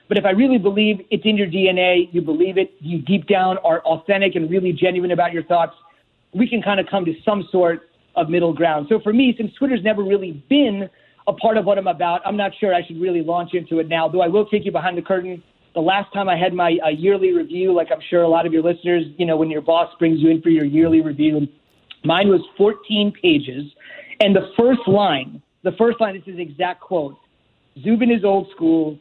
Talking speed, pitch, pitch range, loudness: 240 wpm, 180 Hz, 165-200 Hz, -18 LUFS